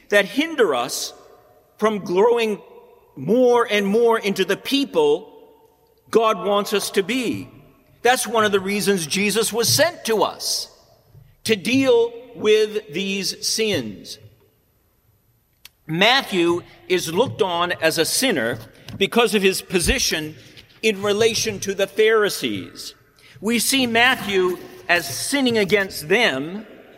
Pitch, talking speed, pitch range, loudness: 210 Hz, 120 wpm, 180-235 Hz, -19 LUFS